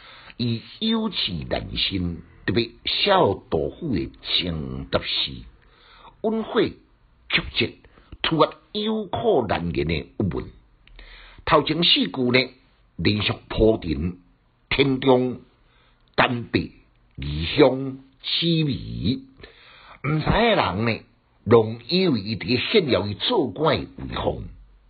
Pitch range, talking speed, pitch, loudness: 105-155 Hz, 145 characters per minute, 125 Hz, -23 LUFS